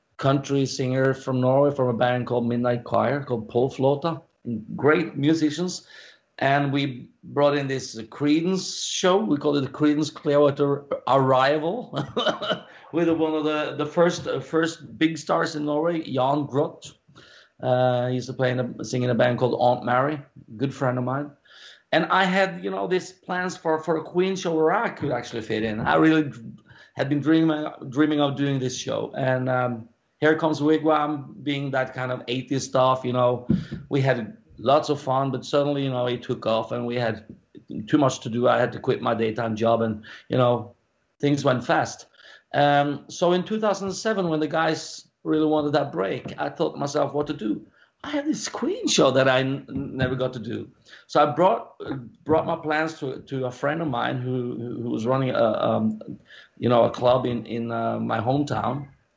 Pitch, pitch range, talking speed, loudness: 140 Hz, 125-155 Hz, 195 wpm, -24 LUFS